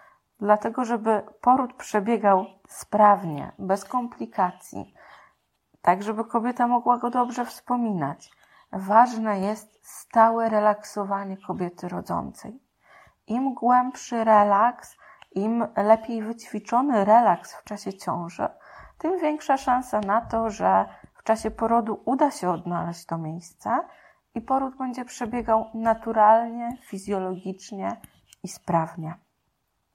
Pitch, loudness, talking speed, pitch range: 225 Hz, -24 LUFS, 105 wpm, 195-245 Hz